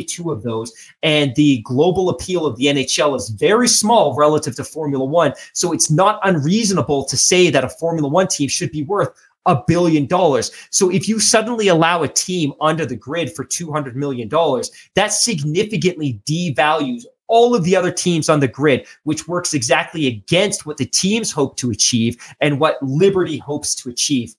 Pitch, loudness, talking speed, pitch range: 155 Hz, -17 LUFS, 180 wpm, 140-180 Hz